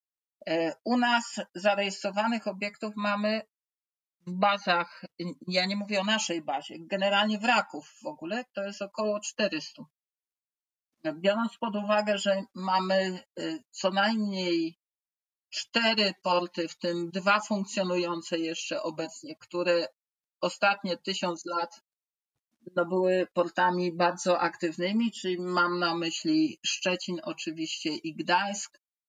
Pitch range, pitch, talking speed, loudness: 175-210 Hz, 190 Hz, 110 wpm, -29 LUFS